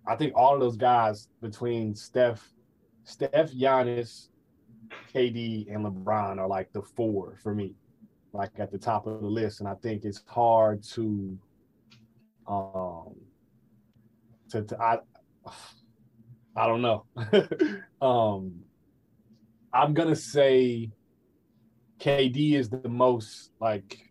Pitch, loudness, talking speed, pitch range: 115 Hz, -27 LUFS, 120 wpm, 105-120 Hz